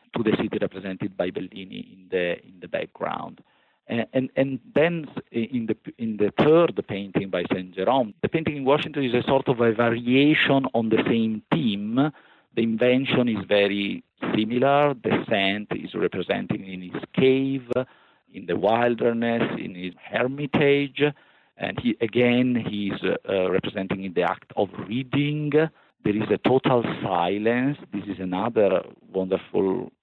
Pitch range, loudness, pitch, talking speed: 105-140 Hz, -24 LUFS, 120 Hz, 155 wpm